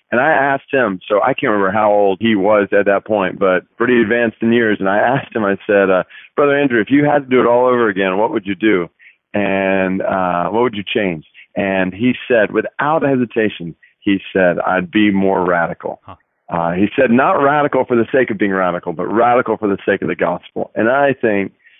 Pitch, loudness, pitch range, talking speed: 105 Hz, -15 LUFS, 95-125 Hz, 225 wpm